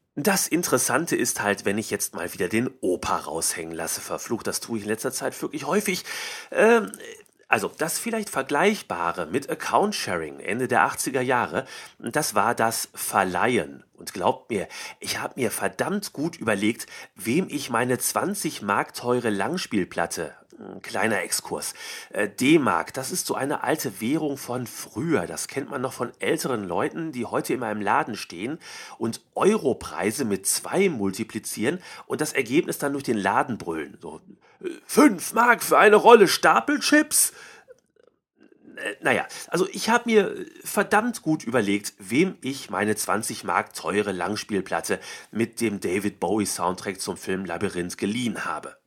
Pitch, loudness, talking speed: 140 Hz, -24 LUFS, 150 wpm